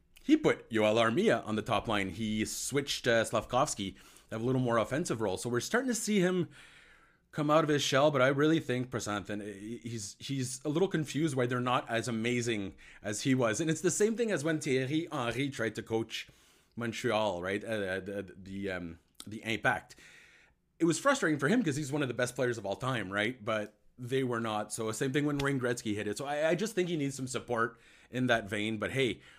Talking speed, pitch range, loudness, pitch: 225 wpm, 110-145 Hz, -32 LUFS, 120 Hz